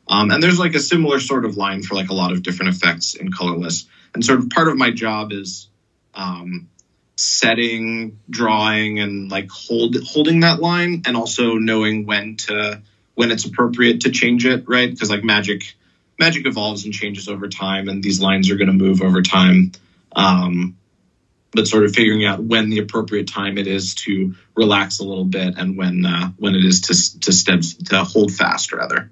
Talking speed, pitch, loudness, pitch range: 195 wpm, 105 Hz, -17 LUFS, 95-115 Hz